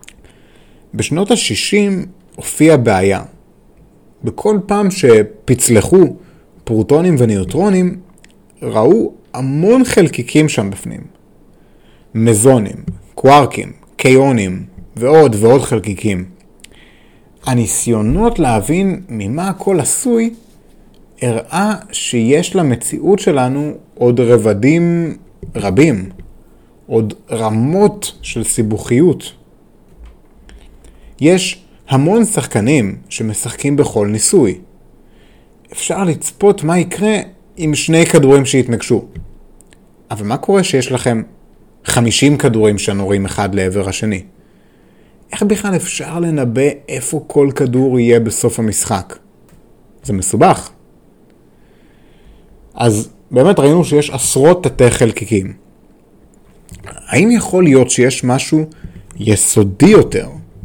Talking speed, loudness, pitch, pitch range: 85 wpm, -13 LUFS, 130 Hz, 110-170 Hz